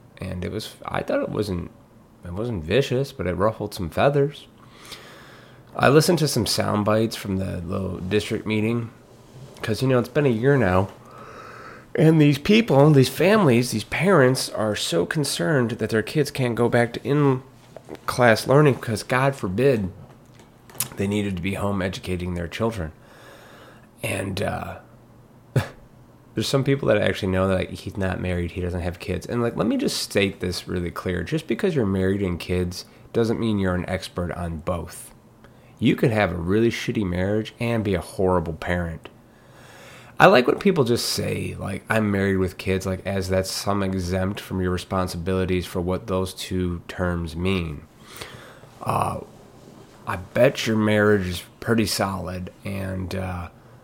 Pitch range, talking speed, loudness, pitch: 95-120 Hz, 165 wpm, -23 LUFS, 105 Hz